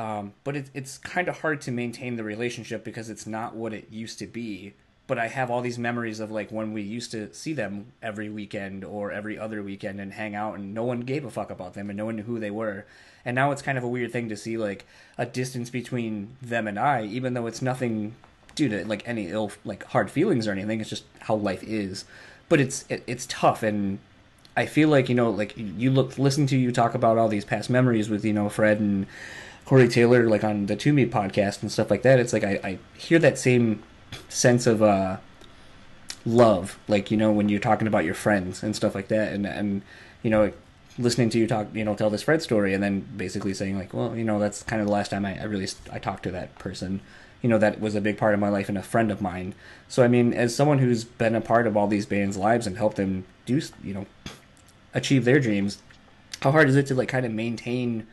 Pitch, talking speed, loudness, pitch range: 110 Hz, 250 wpm, -25 LUFS, 105-120 Hz